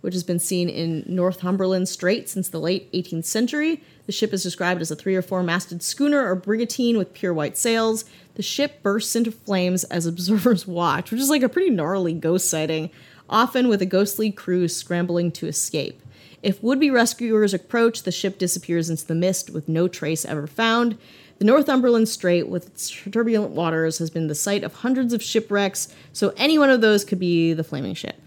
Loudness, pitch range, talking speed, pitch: -22 LUFS, 170-225 Hz, 200 wpm, 185 Hz